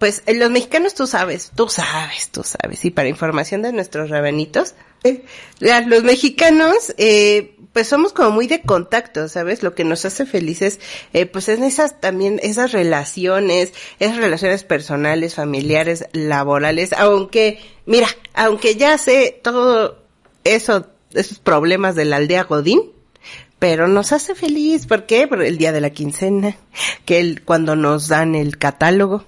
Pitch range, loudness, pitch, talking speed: 165-235 Hz, -16 LUFS, 195 Hz, 160 wpm